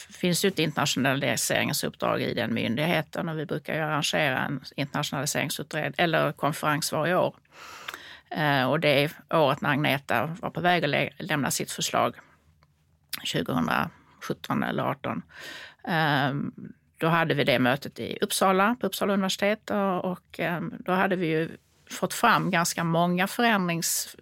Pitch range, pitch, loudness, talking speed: 160-195 Hz, 180 Hz, -26 LUFS, 140 wpm